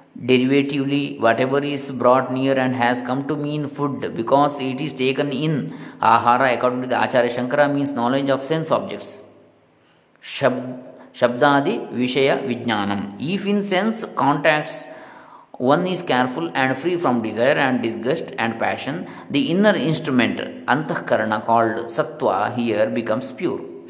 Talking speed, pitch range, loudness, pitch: 140 wpm, 125-145 Hz, -20 LUFS, 130 Hz